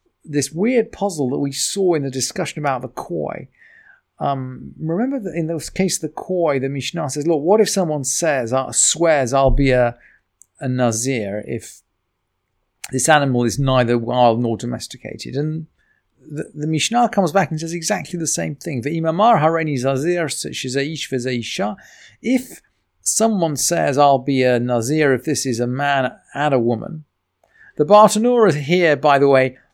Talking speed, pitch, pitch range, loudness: 155 wpm, 145 Hz, 130-170 Hz, -18 LUFS